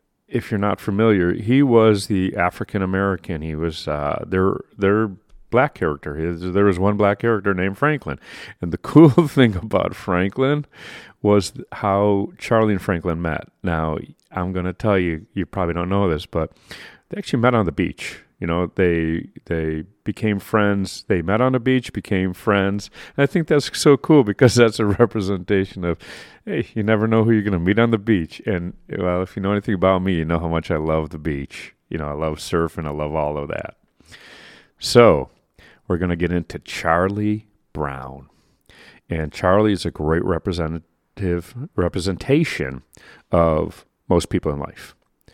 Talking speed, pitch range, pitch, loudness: 180 wpm, 85-110 Hz, 95 Hz, -20 LUFS